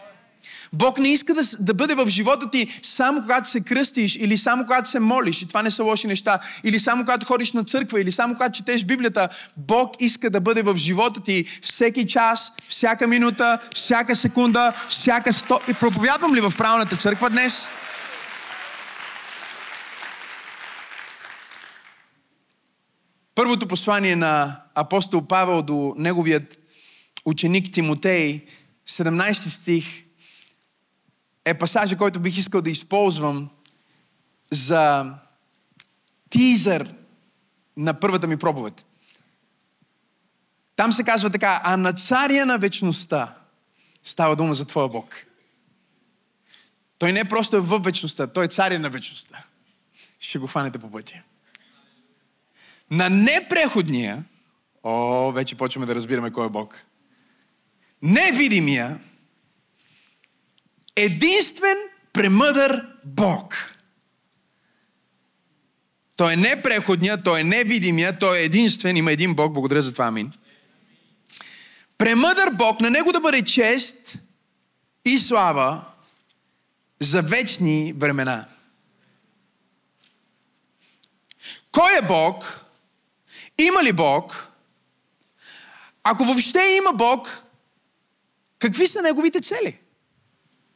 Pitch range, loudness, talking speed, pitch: 160-240 Hz, -20 LUFS, 110 wpm, 200 Hz